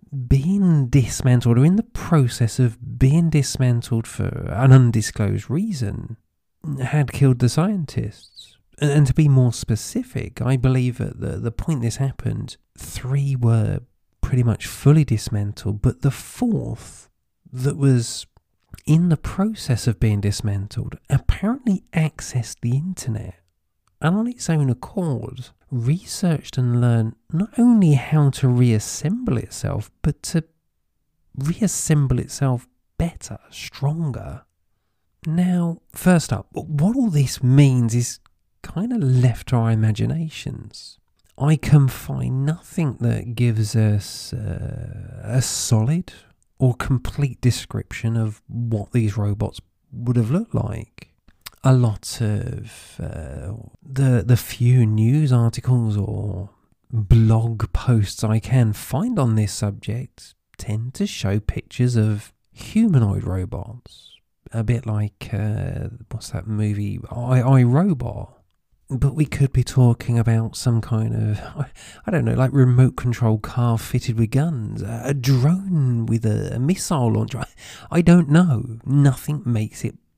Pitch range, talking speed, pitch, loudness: 110-140 Hz, 130 wpm, 120 Hz, -20 LUFS